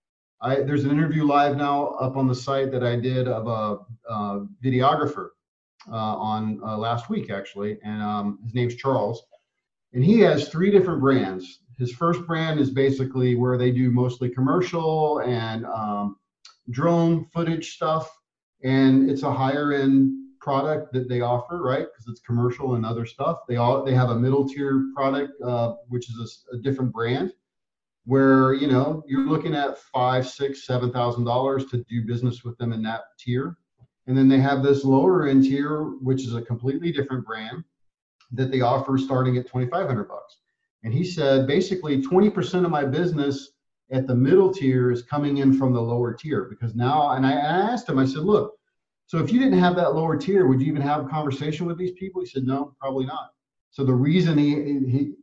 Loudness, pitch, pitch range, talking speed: -23 LUFS, 135 Hz, 120-145 Hz, 195 wpm